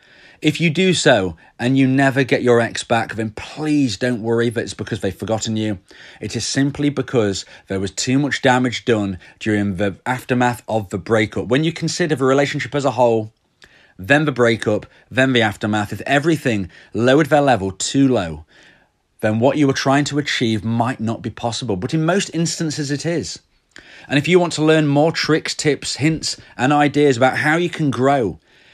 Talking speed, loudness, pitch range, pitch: 190 wpm, -18 LUFS, 110-145 Hz, 125 Hz